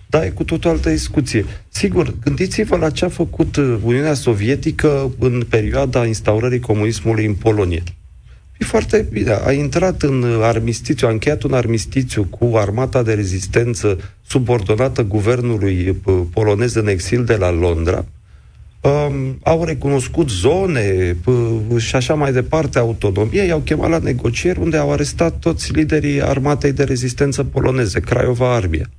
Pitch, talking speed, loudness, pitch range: 125 Hz, 135 wpm, -17 LUFS, 105-145 Hz